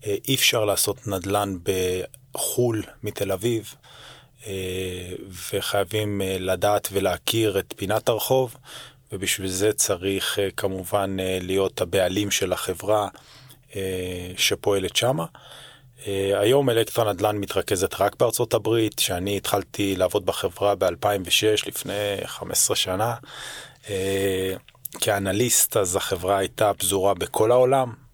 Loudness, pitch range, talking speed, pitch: -23 LUFS, 95-115 Hz, 95 wpm, 100 Hz